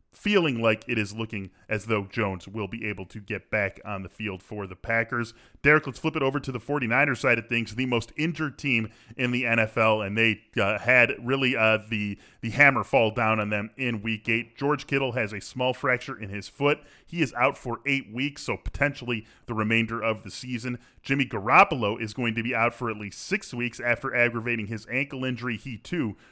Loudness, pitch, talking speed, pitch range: -26 LUFS, 115 Hz, 215 wpm, 110-130 Hz